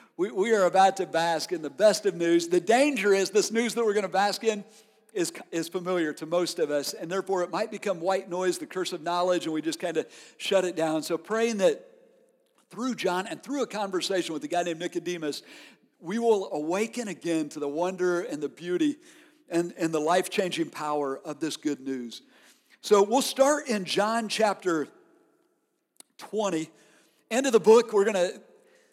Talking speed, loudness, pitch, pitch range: 195 wpm, -27 LUFS, 190 Hz, 170-235 Hz